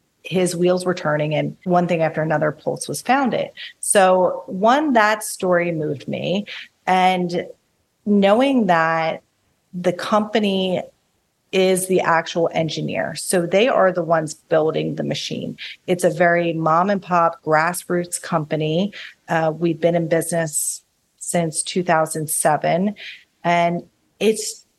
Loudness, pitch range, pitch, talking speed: -19 LUFS, 160-185 Hz, 175 Hz, 125 wpm